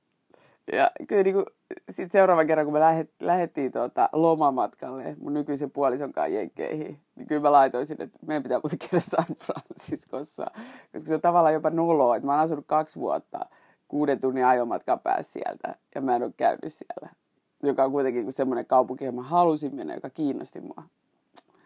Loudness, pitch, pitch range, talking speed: -25 LUFS, 150 Hz, 135-165 Hz, 170 wpm